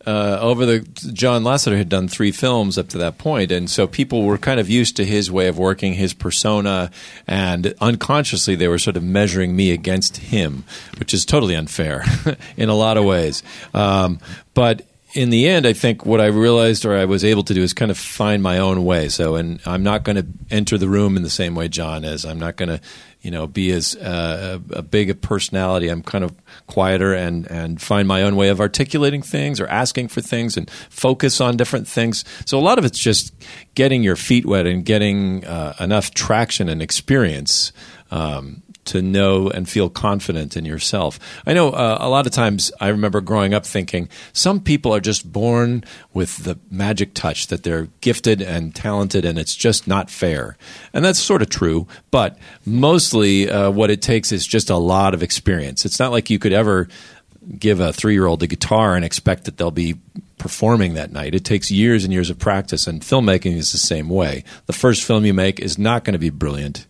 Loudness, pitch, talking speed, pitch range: -18 LUFS, 100 Hz, 215 wpm, 90-110 Hz